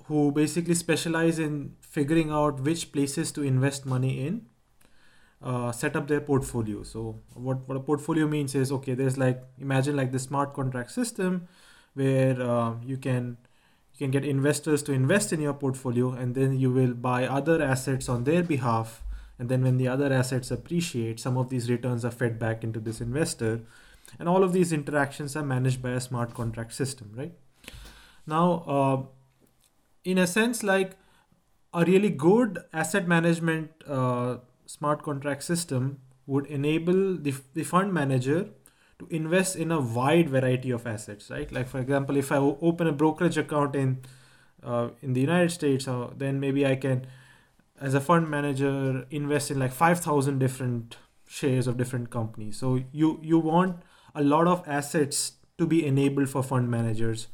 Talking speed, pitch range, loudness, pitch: 170 wpm, 130-160 Hz, -27 LUFS, 140 Hz